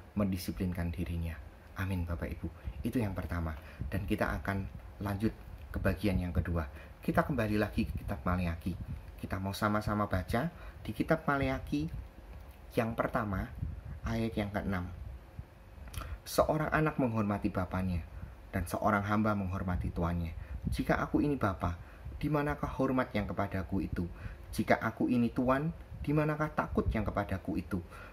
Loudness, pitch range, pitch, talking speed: -34 LUFS, 85-105 Hz, 95 Hz, 130 wpm